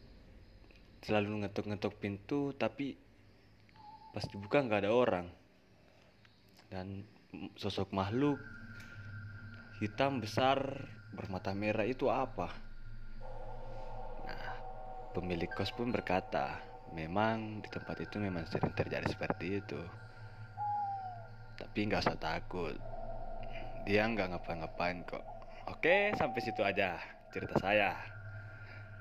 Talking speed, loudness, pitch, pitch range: 95 wpm, -37 LUFS, 110 Hz, 100-120 Hz